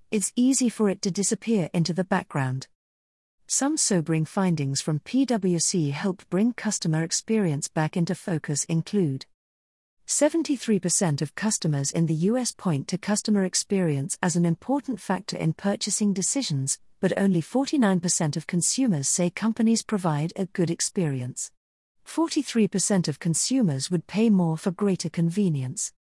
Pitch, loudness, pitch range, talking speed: 185 Hz, -25 LUFS, 160-210 Hz, 135 wpm